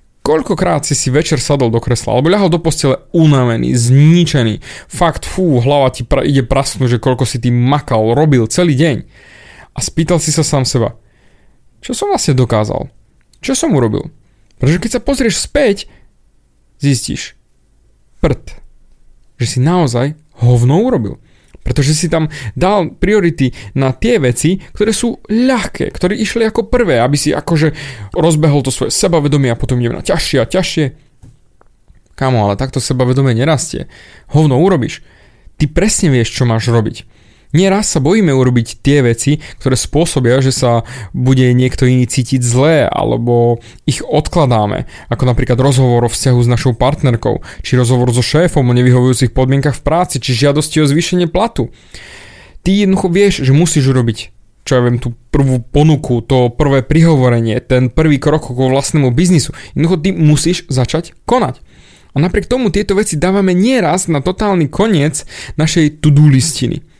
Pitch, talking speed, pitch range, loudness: 140 Hz, 155 wpm, 125-165 Hz, -12 LUFS